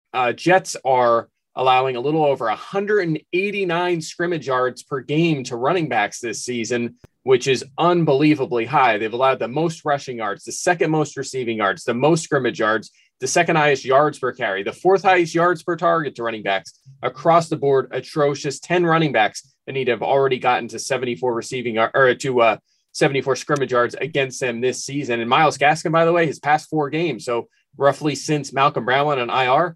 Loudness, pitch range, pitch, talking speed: -20 LUFS, 125-165 Hz, 140 Hz, 190 wpm